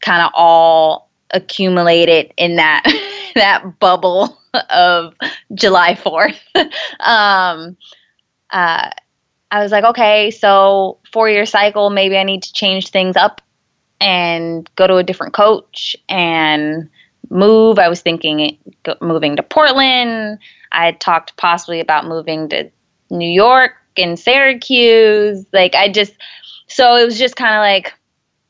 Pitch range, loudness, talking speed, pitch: 170-220 Hz, -12 LUFS, 135 wpm, 195 Hz